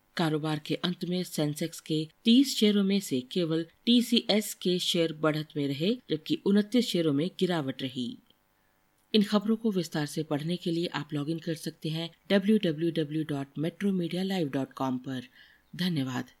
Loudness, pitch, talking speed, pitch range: -29 LUFS, 165 Hz, 145 wpm, 155-195 Hz